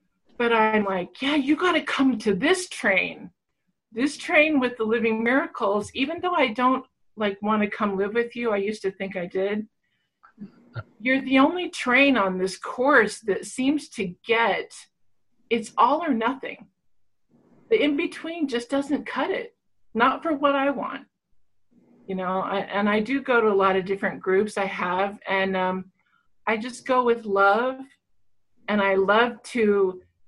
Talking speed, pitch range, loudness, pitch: 170 wpm, 200-275 Hz, -23 LUFS, 230 Hz